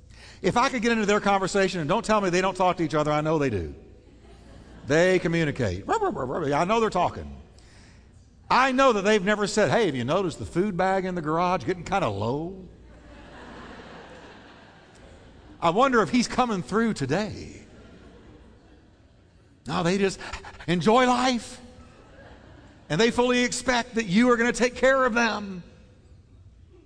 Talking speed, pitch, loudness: 160 wpm, 180 Hz, -24 LUFS